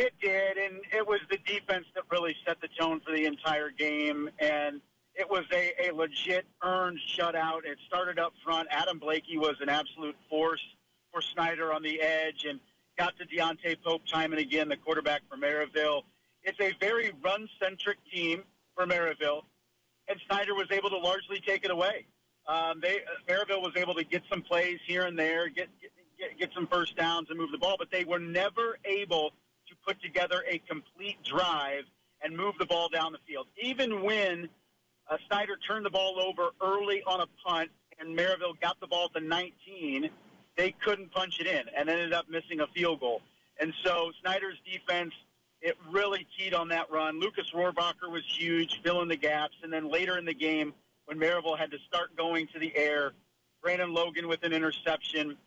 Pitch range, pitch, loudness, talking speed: 160-190 Hz, 170 Hz, -31 LUFS, 195 wpm